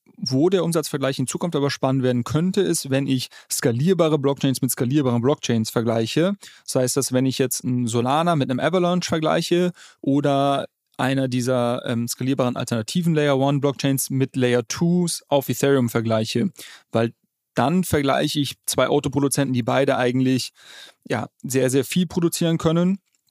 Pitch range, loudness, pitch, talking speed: 125-155 Hz, -21 LUFS, 135 Hz, 150 wpm